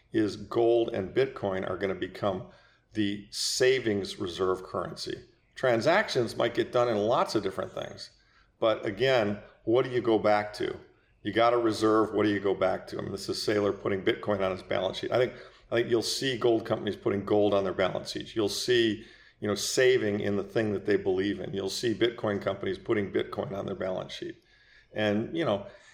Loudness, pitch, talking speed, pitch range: -28 LUFS, 105 Hz, 205 wpm, 100-115 Hz